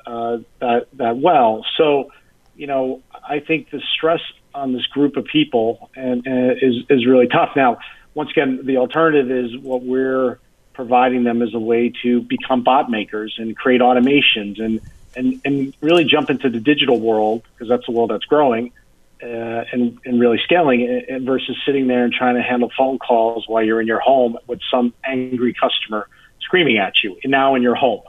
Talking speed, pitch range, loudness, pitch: 190 wpm, 115-135 Hz, -17 LUFS, 125 Hz